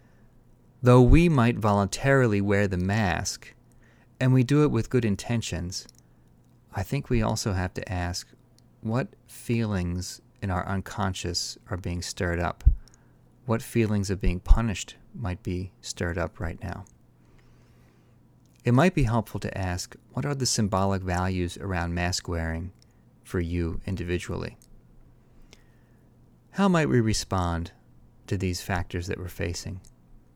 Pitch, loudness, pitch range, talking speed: 100 Hz, -27 LUFS, 90-120 Hz, 135 wpm